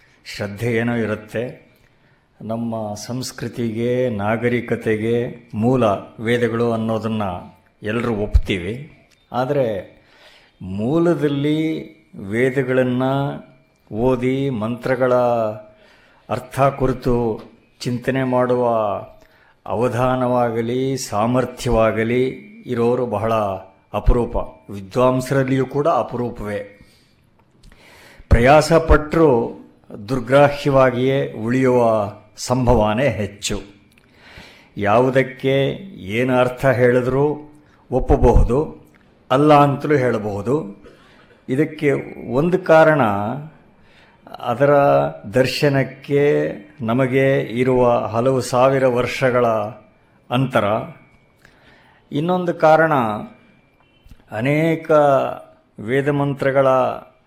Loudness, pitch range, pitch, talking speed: -18 LUFS, 115-135 Hz, 125 Hz, 60 wpm